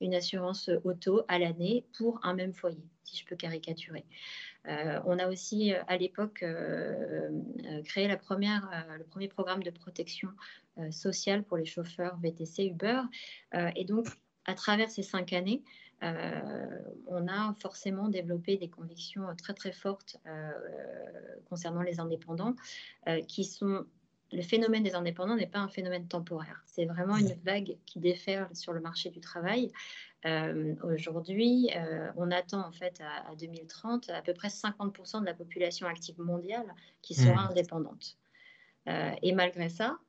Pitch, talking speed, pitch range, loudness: 180 Hz, 160 wpm, 170-200 Hz, -34 LUFS